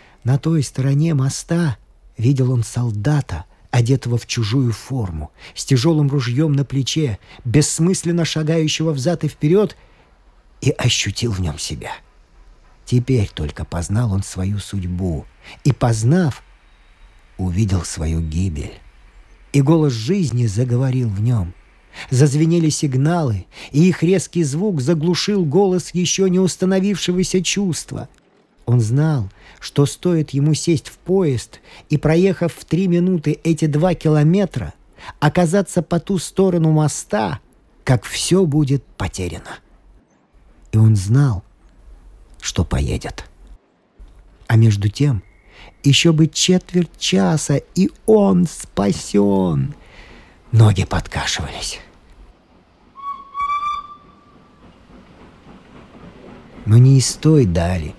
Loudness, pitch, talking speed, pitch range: -18 LUFS, 140 Hz, 105 wpm, 110-170 Hz